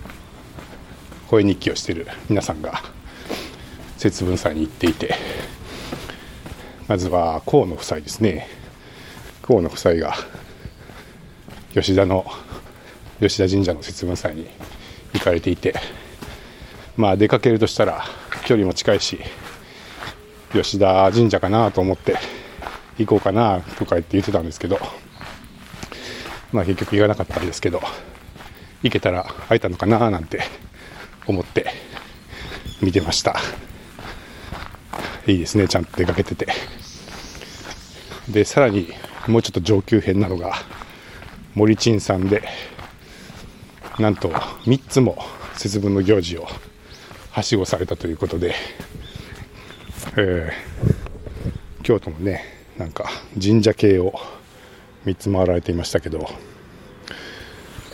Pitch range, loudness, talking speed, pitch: 95-110 Hz, -20 LUFS, 225 characters per minute, 100 Hz